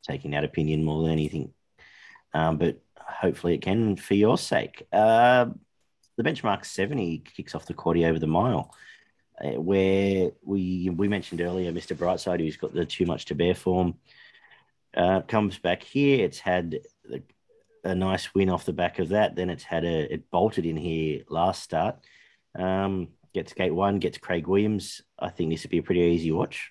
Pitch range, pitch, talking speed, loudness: 80-100 Hz, 90 Hz, 185 wpm, -26 LUFS